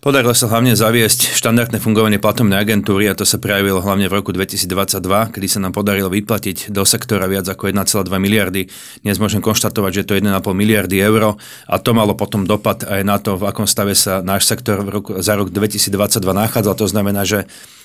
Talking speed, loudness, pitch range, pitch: 200 wpm, -15 LUFS, 100-110 Hz, 100 Hz